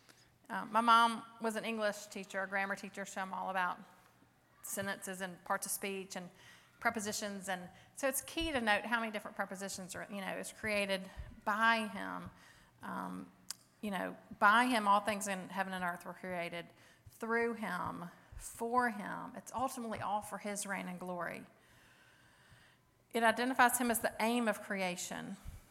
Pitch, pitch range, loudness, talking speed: 205 Hz, 190-230 Hz, -36 LUFS, 165 wpm